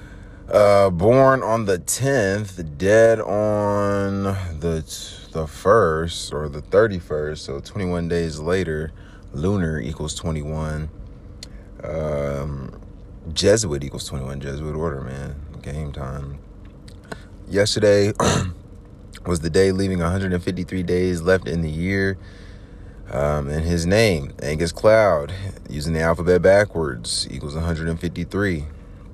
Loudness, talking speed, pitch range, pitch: -21 LUFS, 135 wpm, 75-100 Hz, 90 Hz